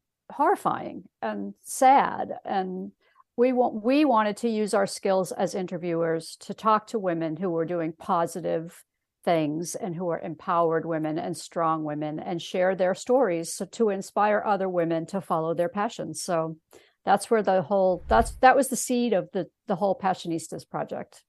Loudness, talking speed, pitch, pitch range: -26 LUFS, 170 wpm, 185 Hz, 165-210 Hz